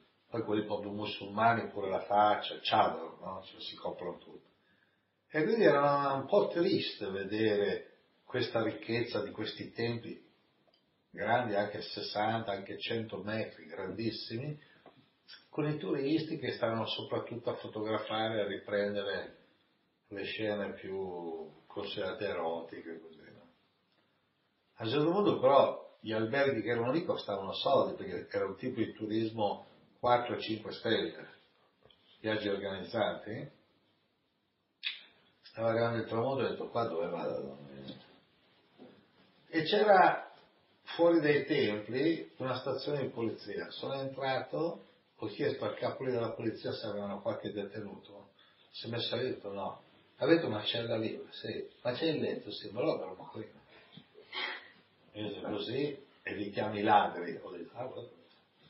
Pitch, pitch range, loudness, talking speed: 110 Hz, 100-120 Hz, -34 LUFS, 130 wpm